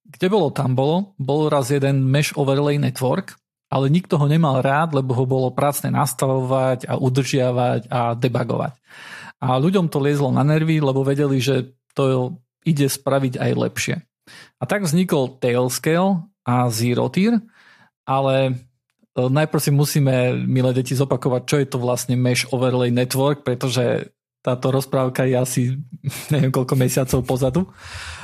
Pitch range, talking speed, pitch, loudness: 125-145 Hz, 145 wpm, 135 Hz, -20 LUFS